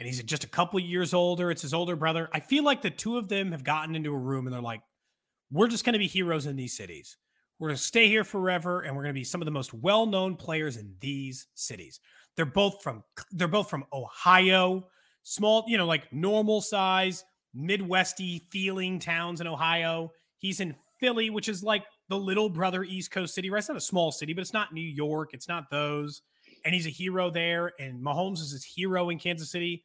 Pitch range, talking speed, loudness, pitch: 155-190 Hz, 220 wpm, -28 LUFS, 175 Hz